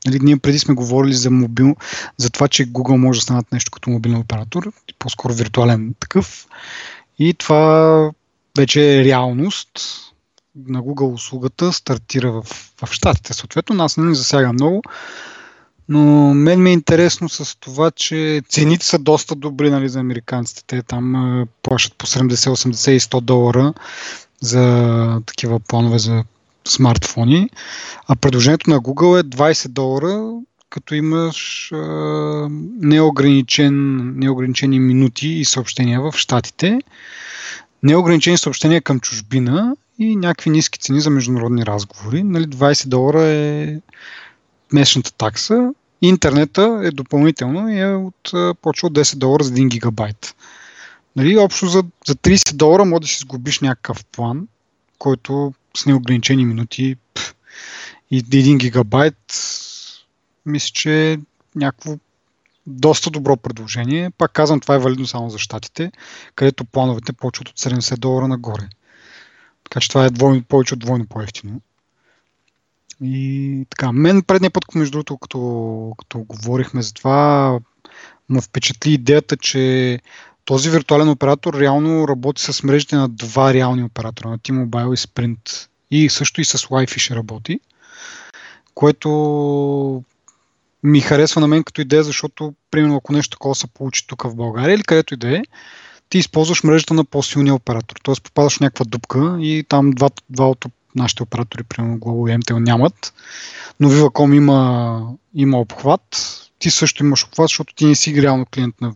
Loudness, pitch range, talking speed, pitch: -16 LUFS, 125-155 Hz, 145 wpm, 135 Hz